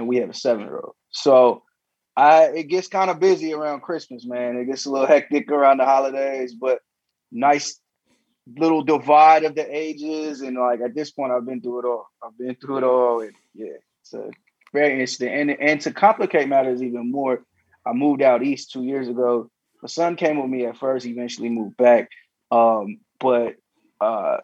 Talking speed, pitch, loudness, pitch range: 195 wpm, 135 Hz, -20 LUFS, 125-155 Hz